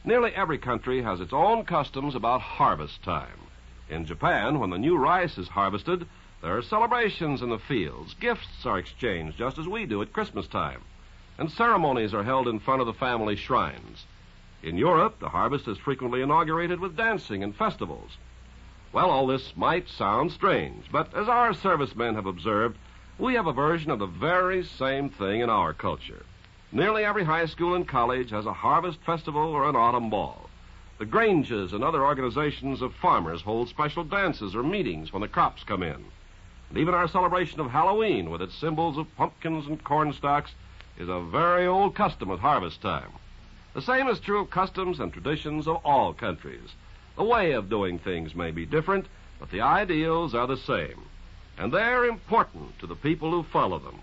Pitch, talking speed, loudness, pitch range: 145 Hz, 185 wpm, -26 LUFS, 105-175 Hz